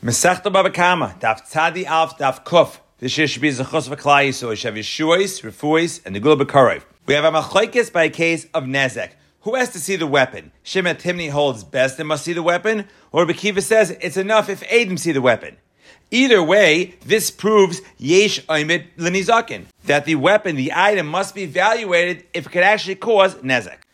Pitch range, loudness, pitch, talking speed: 145-195 Hz, -17 LUFS, 170 Hz, 165 wpm